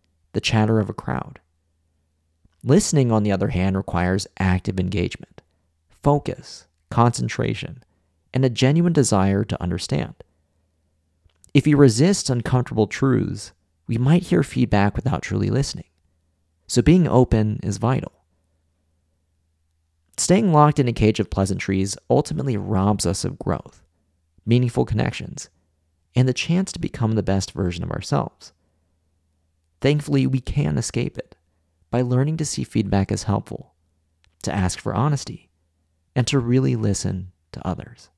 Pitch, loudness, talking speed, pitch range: 95 Hz, -21 LUFS, 130 wpm, 80-125 Hz